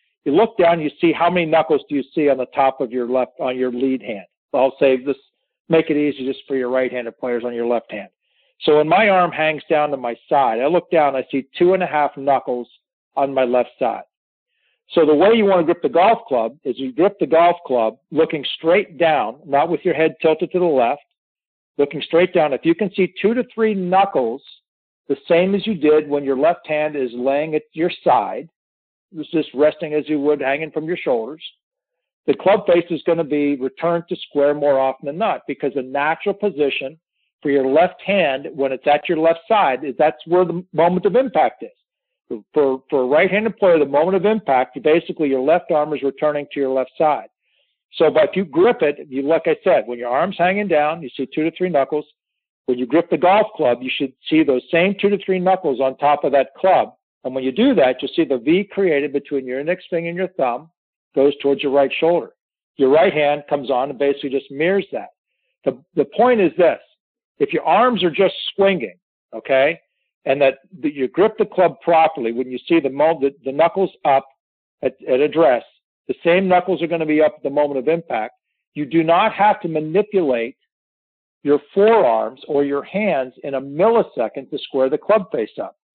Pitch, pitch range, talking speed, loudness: 155 Hz, 135-180 Hz, 220 wpm, -18 LUFS